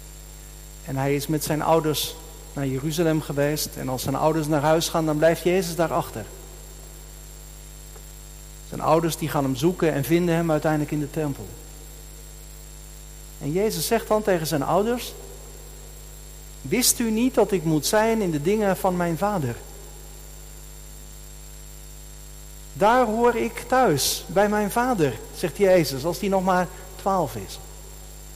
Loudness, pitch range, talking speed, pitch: -23 LUFS, 150-190 Hz, 145 wpm, 160 Hz